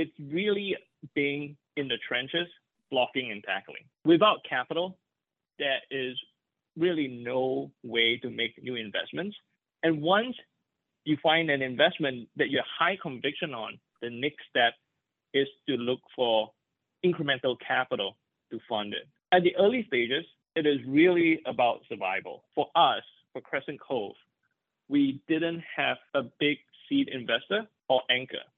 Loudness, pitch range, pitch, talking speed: -28 LUFS, 125-175 Hz, 145 Hz, 140 wpm